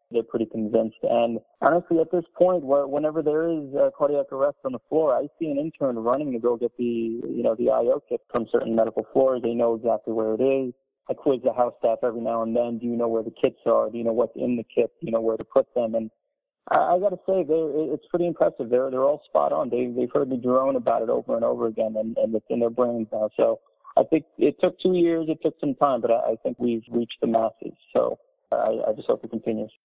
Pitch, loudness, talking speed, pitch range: 125 Hz, -24 LUFS, 260 wpm, 115-155 Hz